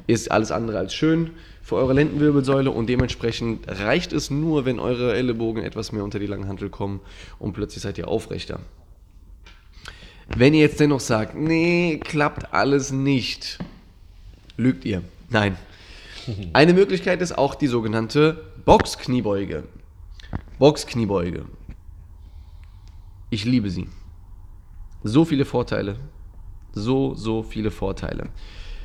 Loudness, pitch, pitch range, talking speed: -22 LUFS, 110 Hz, 90-135 Hz, 120 wpm